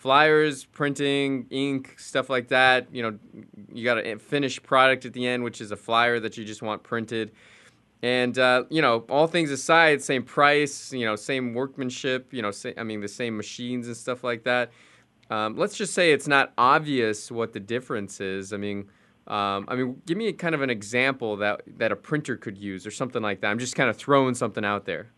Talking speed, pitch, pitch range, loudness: 215 wpm, 125 Hz, 110-135 Hz, -25 LUFS